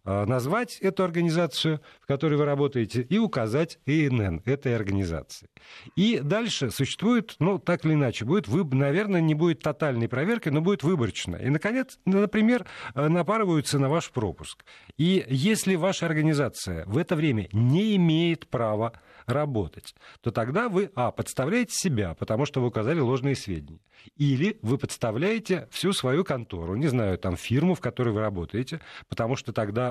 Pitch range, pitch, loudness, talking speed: 120-180 Hz, 145 Hz, -26 LUFS, 155 wpm